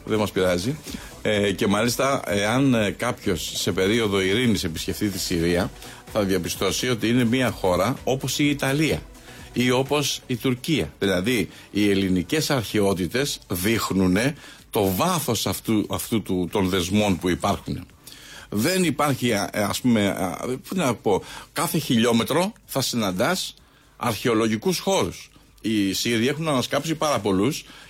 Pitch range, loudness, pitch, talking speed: 100-135 Hz, -23 LUFS, 115 Hz, 130 wpm